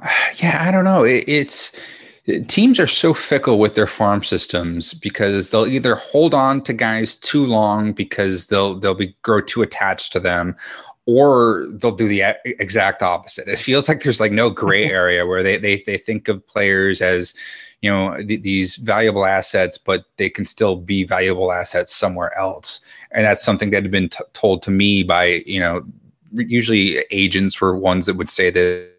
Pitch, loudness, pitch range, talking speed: 100 Hz, -17 LUFS, 95-110 Hz, 185 wpm